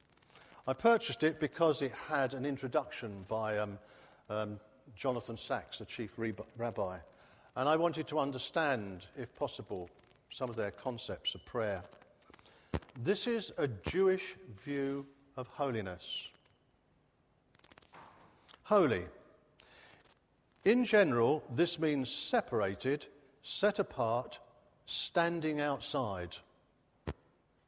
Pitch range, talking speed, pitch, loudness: 110-155 Hz, 100 wpm, 135 Hz, -35 LUFS